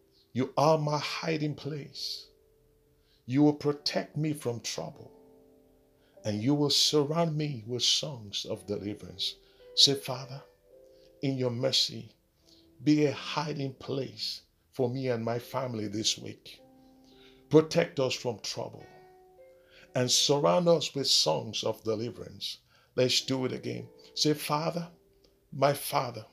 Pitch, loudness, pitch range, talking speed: 135 Hz, -29 LUFS, 115-150 Hz, 125 wpm